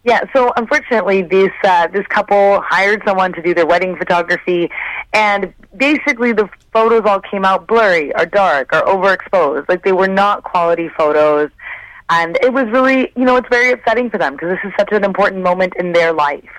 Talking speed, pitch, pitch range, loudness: 190 wpm, 200 Hz, 175-230 Hz, -13 LUFS